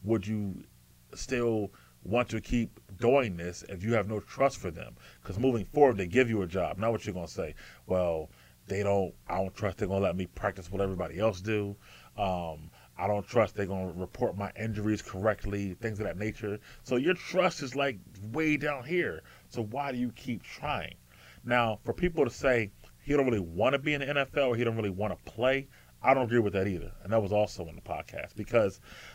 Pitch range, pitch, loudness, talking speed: 95-120 Hz, 105 Hz, -31 LUFS, 225 wpm